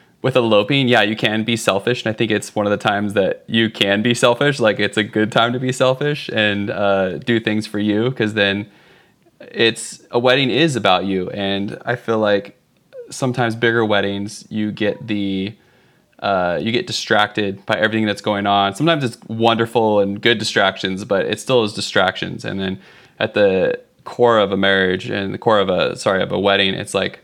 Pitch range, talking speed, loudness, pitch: 100-120 Hz, 200 wpm, -17 LUFS, 110 Hz